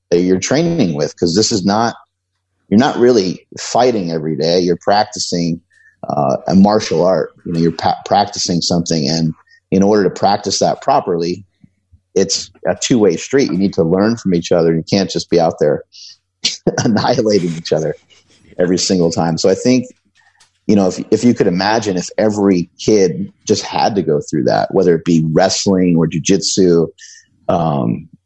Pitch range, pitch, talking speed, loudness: 85-100 Hz, 90 Hz, 175 wpm, -14 LUFS